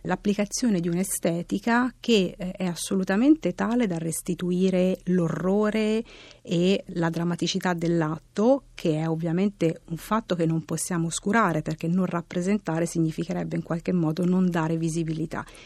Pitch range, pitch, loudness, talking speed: 165-195 Hz, 180 Hz, -25 LUFS, 125 wpm